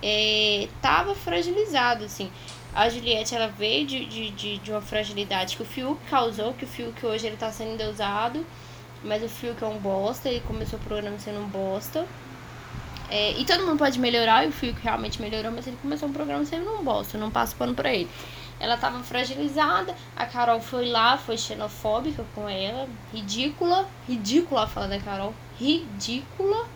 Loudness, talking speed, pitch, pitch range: -26 LUFS, 185 wpm, 225 Hz, 205-265 Hz